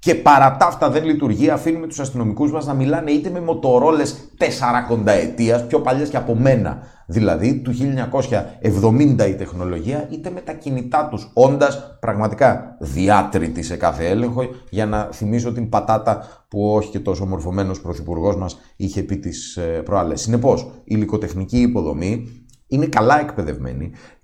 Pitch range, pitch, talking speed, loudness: 100-135 Hz, 115 Hz, 150 wpm, -19 LUFS